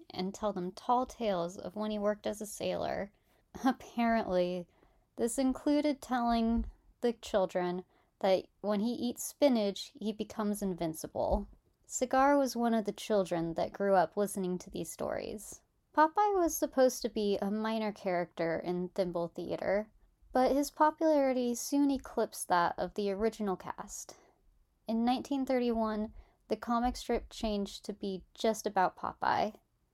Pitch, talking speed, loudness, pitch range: 215 Hz, 140 wpm, -33 LUFS, 190-250 Hz